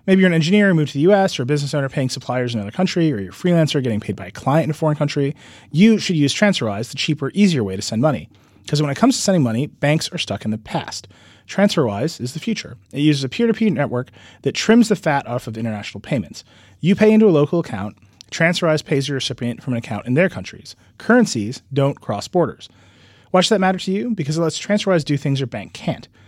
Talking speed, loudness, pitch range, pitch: 245 wpm, -19 LUFS, 115-180 Hz, 145 Hz